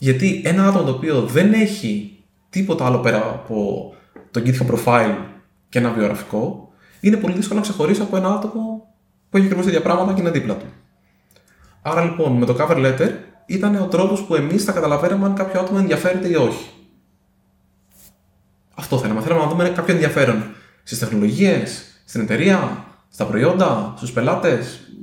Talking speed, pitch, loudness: 165 wpm, 155 Hz, -19 LUFS